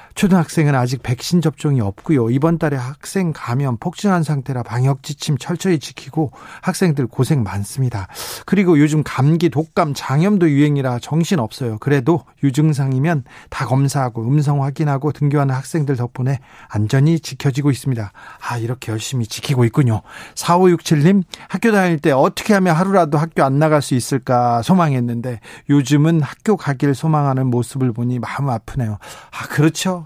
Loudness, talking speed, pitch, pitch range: -17 LUFS, 355 characters per minute, 145 Hz, 125-165 Hz